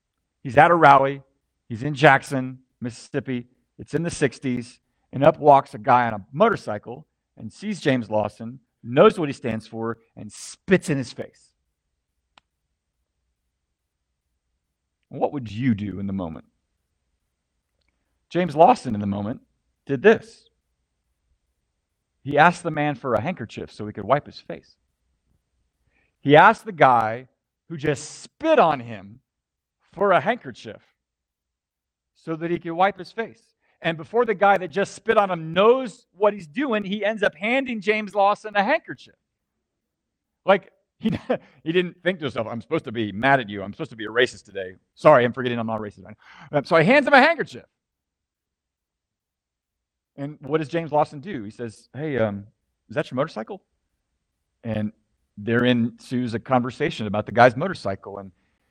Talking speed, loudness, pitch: 165 wpm, -21 LUFS, 120 Hz